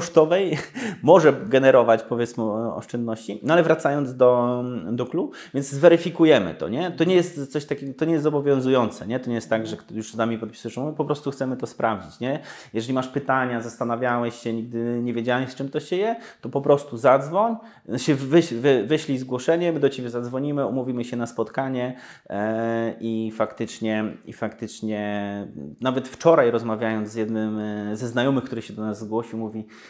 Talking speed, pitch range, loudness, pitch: 180 wpm, 115-140 Hz, -23 LUFS, 125 Hz